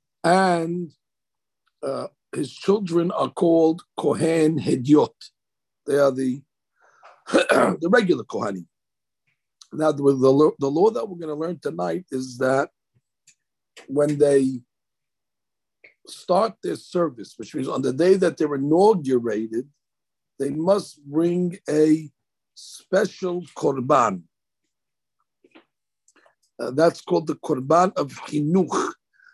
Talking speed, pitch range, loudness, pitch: 105 wpm, 140-175 Hz, -22 LUFS, 155 Hz